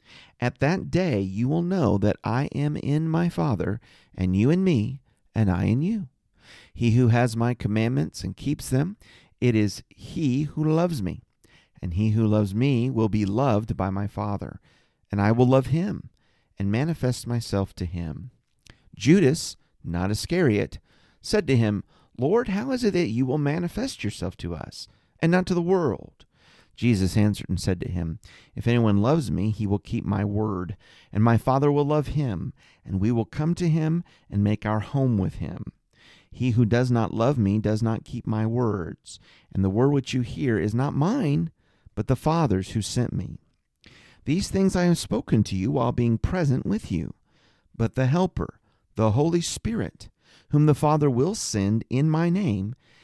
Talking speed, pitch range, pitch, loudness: 185 wpm, 105-150 Hz, 120 Hz, -24 LUFS